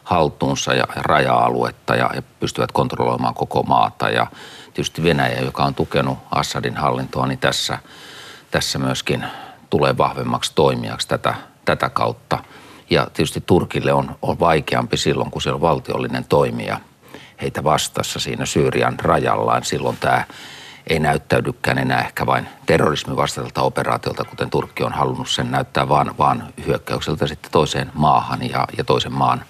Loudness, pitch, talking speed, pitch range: -19 LUFS, 65 Hz, 140 wpm, 60-70 Hz